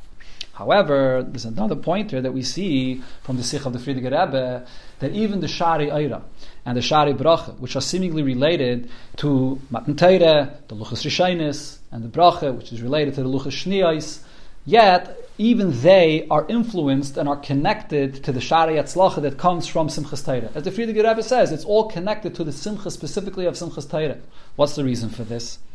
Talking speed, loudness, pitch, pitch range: 180 wpm, -21 LUFS, 150 Hz, 130-175 Hz